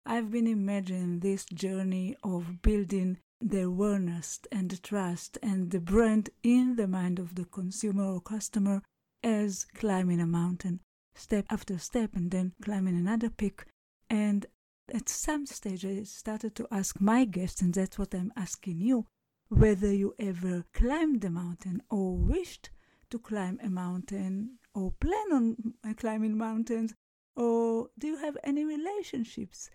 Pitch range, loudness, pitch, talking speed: 185-230 Hz, -31 LUFS, 205 Hz, 150 wpm